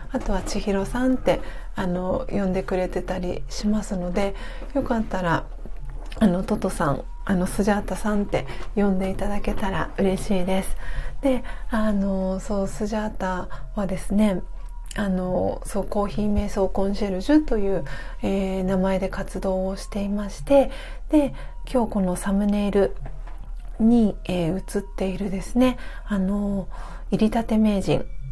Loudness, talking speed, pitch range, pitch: -24 LUFS, 285 characters per minute, 190-215 Hz, 200 Hz